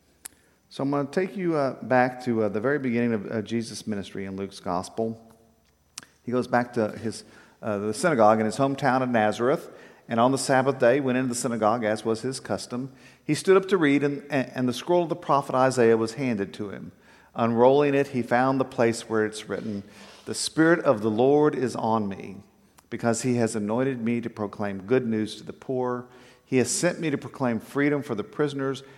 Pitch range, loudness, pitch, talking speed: 110-135 Hz, -25 LUFS, 125 Hz, 210 wpm